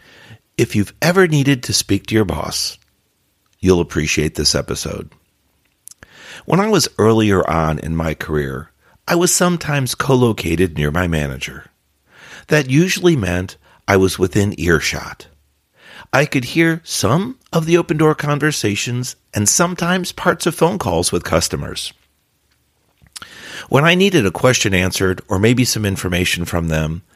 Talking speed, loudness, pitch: 145 wpm, -16 LUFS, 105 Hz